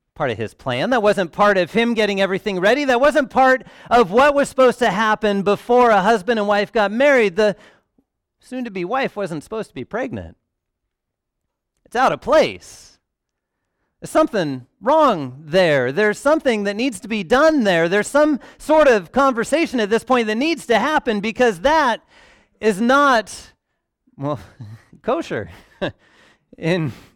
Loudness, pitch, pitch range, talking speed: -18 LUFS, 220 Hz, 190-260 Hz, 160 wpm